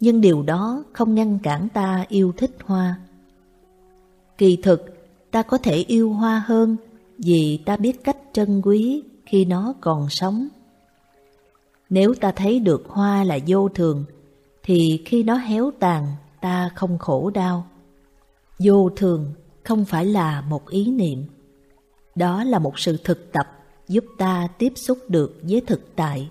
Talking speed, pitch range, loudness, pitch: 155 wpm, 160-220 Hz, -20 LUFS, 185 Hz